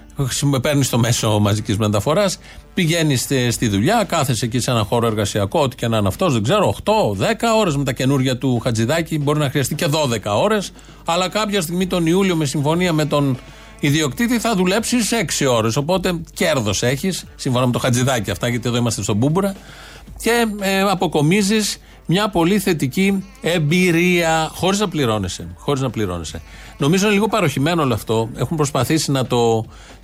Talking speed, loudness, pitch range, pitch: 165 wpm, -18 LUFS, 120-185 Hz, 145 Hz